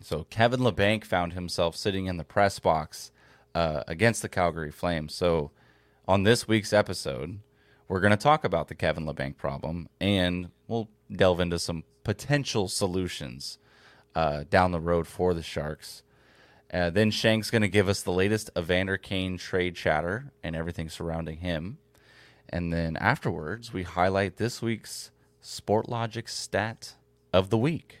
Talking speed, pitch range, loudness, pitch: 155 wpm, 85-110 Hz, -28 LUFS, 95 Hz